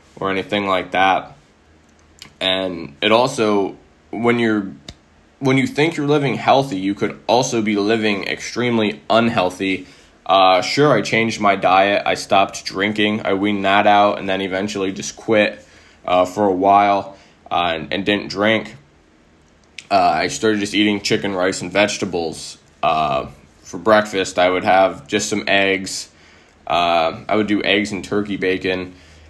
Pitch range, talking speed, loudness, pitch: 90-105 Hz, 155 wpm, -17 LUFS, 100 Hz